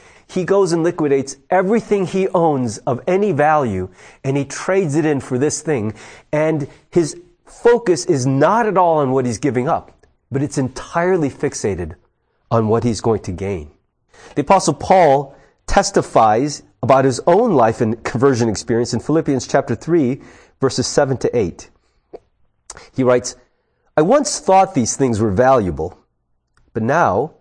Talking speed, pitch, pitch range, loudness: 155 wpm, 140 Hz, 120-175 Hz, -17 LUFS